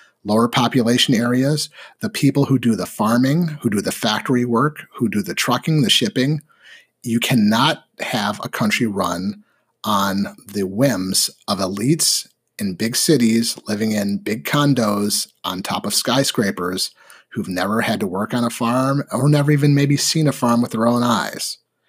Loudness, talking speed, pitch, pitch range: -19 LUFS, 165 wpm, 125 Hz, 115-145 Hz